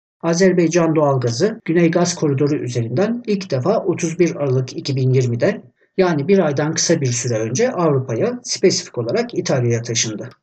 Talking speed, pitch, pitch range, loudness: 130 wpm, 165 Hz, 130-185 Hz, -18 LUFS